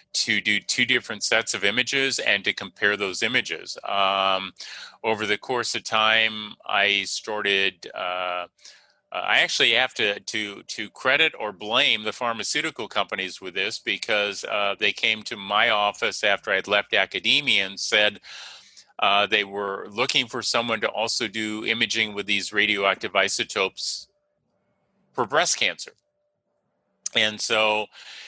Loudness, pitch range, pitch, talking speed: -22 LUFS, 100-110 Hz, 105 Hz, 140 wpm